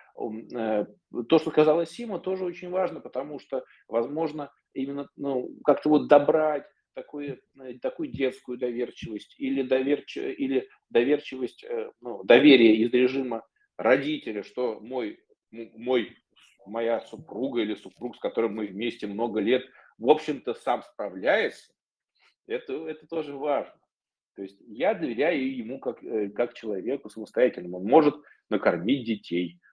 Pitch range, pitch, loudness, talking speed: 115-155 Hz, 135 Hz, -26 LUFS, 125 wpm